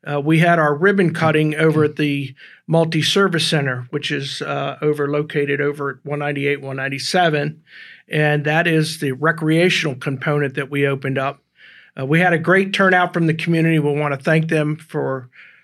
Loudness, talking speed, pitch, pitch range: -18 LUFS, 175 wpm, 150 Hz, 140-160 Hz